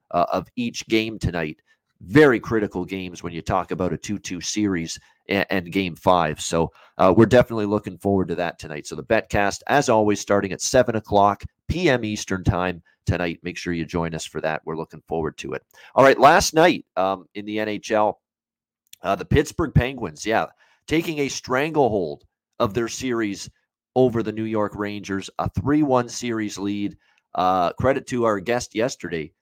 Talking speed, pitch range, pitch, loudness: 180 wpm, 90-115 Hz, 100 Hz, -22 LUFS